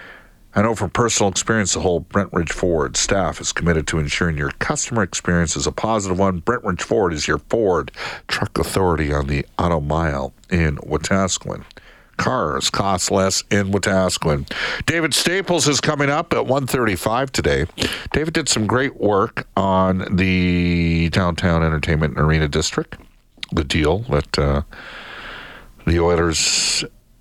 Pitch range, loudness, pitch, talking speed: 80-110 Hz, -19 LUFS, 95 Hz, 150 wpm